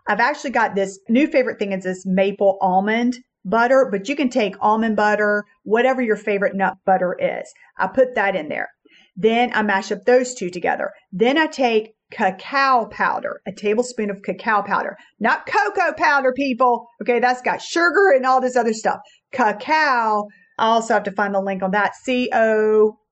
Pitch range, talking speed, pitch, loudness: 200-255 Hz, 185 wpm, 220 Hz, -19 LUFS